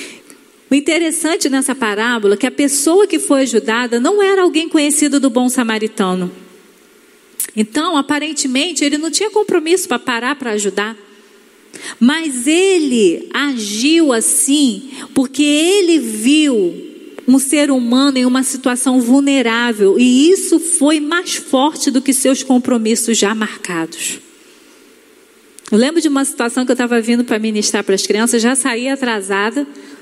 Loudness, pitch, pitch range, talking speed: -14 LUFS, 270 Hz, 235-320 Hz, 140 wpm